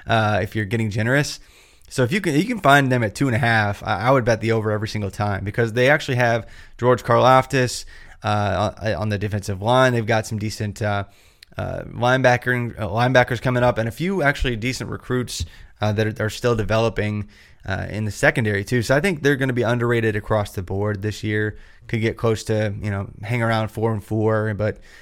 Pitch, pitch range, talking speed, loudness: 110 Hz, 105-125 Hz, 220 wpm, -21 LUFS